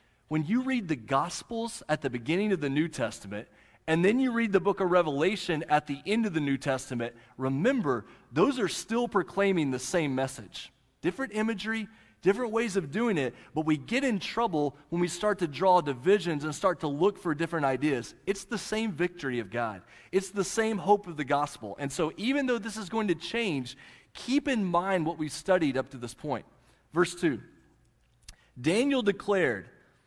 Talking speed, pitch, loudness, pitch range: 190 wpm, 175 Hz, -29 LUFS, 140-210 Hz